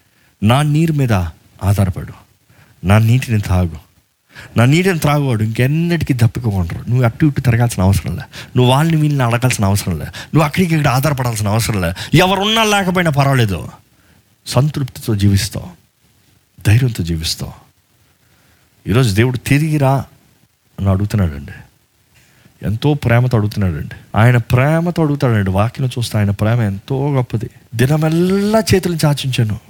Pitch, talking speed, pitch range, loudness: 120 Hz, 120 wpm, 100-145 Hz, -15 LUFS